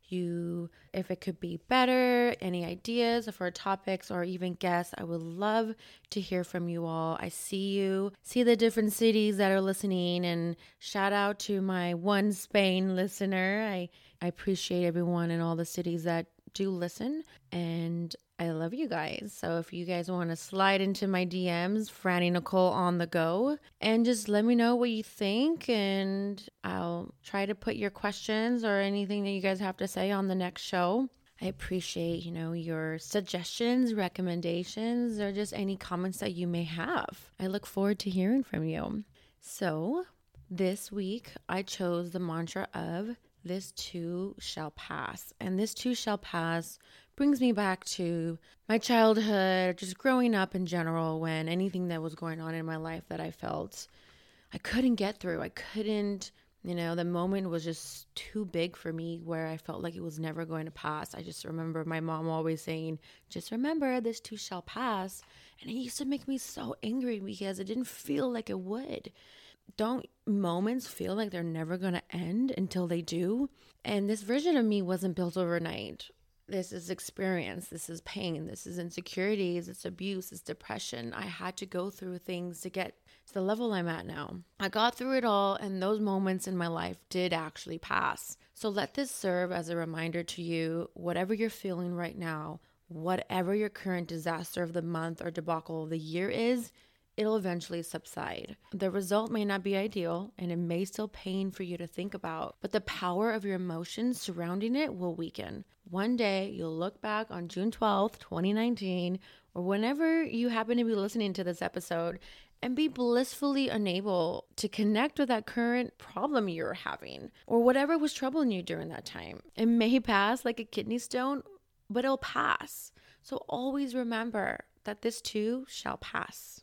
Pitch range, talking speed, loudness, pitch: 175-220 Hz, 185 wpm, -32 LUFS, 190 Hz